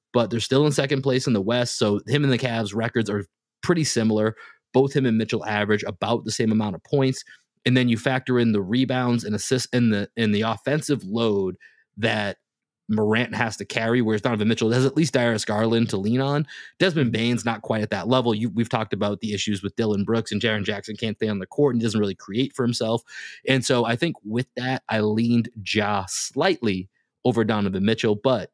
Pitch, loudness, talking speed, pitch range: 115 Hz, -23 LUFS, 220 wpm, 105-125 Hz